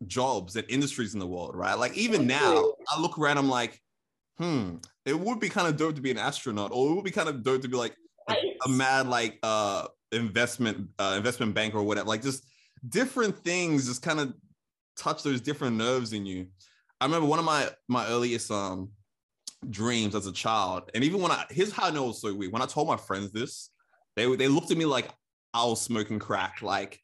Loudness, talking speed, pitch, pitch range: -28 LUFS, 215 wpm, 125 Hz, 110-145 Hz